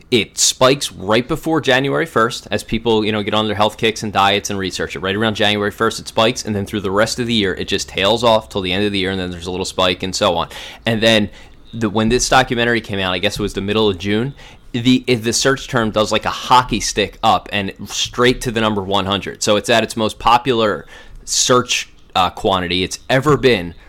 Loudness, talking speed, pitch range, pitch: -16 LUFS, 245 wpm, 100-115 Hz, 110 Hz